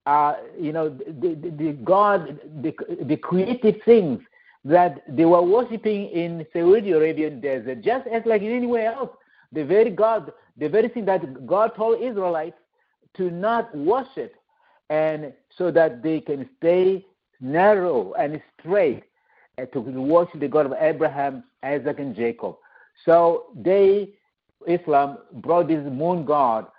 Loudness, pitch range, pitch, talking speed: -22 LUFS, 150-200 Hz, 170 Hz, 145 wpm